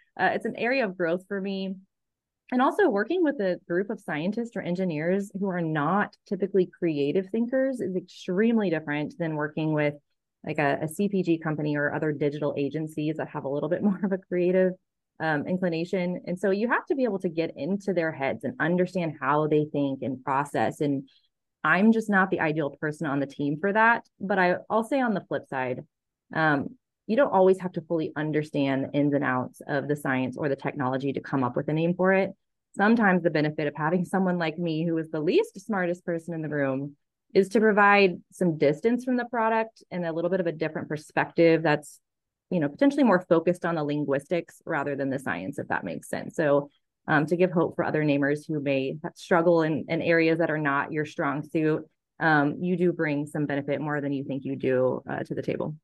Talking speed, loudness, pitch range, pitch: 215 wpm, -26 LUFS, 145-190 Hz, 165 Hz